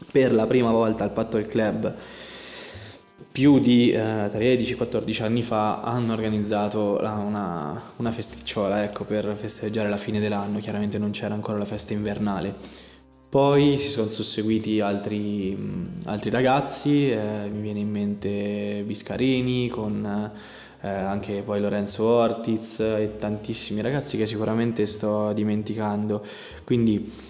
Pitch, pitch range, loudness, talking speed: 105 Hz, 105-115 Hz, -25 LUFS, 135 wpm